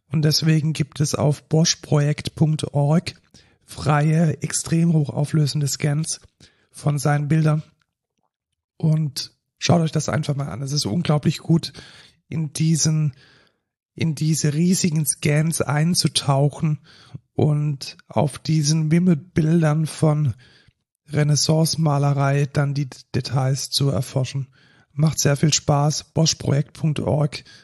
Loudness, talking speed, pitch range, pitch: -21 LUFS, 100 wpm, 140-155 Hz, 150 Hz